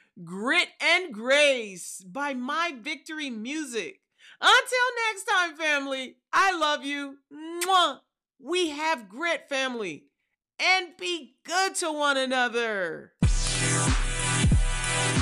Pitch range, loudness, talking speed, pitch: 265-355 Hz, -25 LUFS, 100 wpm, 310 Hz